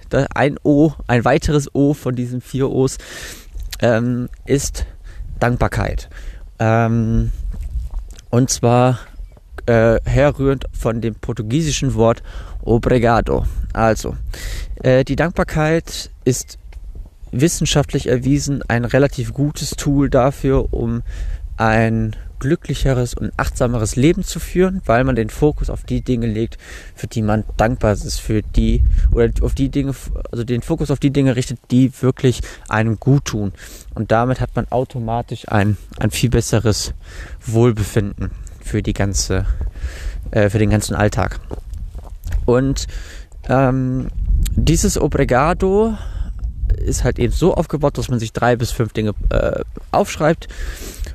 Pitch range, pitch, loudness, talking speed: 95-130 Hz, 115 Hz, -18 LUFS, 130 wpm